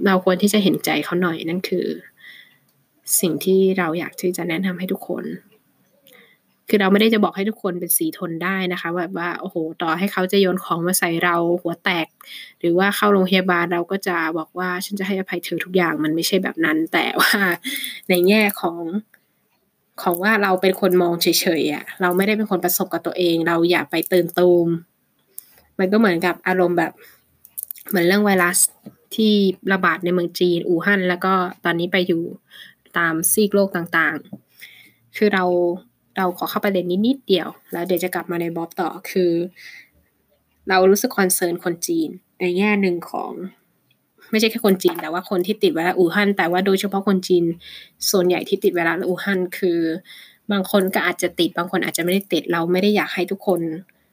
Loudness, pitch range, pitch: -19 LUFS, 175-195 Hz, 180 Hz